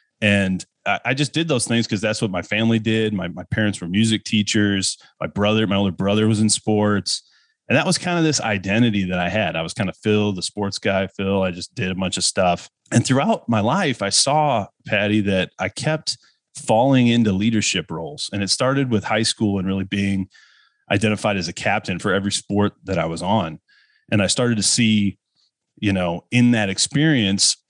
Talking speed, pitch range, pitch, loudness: 210 wpm, 95-115 Hz, 105 Hz, -20 LUFS